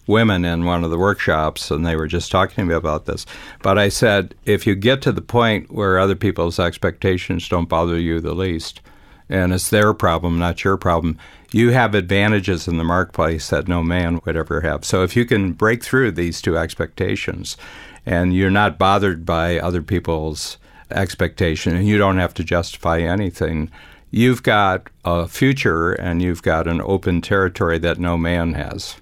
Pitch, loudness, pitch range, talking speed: 90 Hz, -18 LUFS, 85-100 Hz, 185 wpm